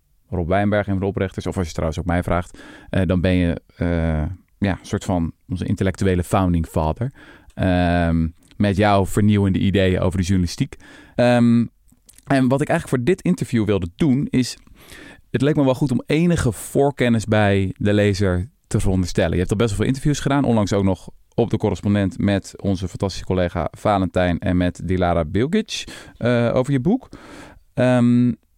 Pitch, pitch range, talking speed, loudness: 100 Hz, 90-120 Hz, 175 wpm, -20 LUFS